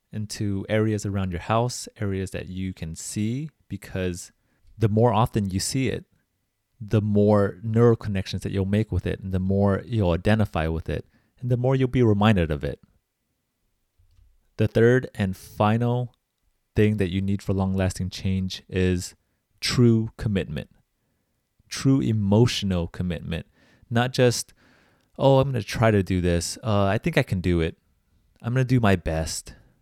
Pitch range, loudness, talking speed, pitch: 95-115 Hz, -24 LUFS, 160 wpm, 100 Hz